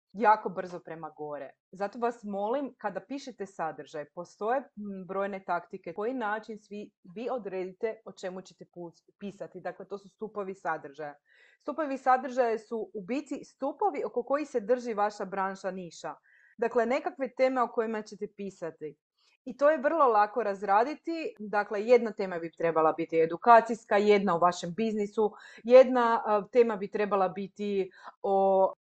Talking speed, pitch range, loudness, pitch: 145 wpm, 185-240 Hz, -29 LUFS, 205 Hz